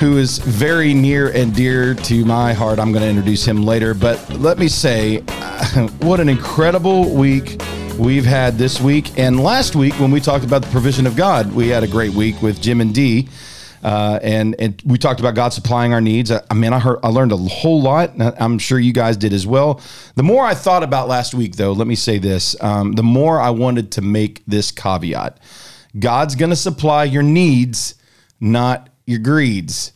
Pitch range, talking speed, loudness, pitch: 110-140 Hz, 210 wpm, -15 LUFS, 120 Hz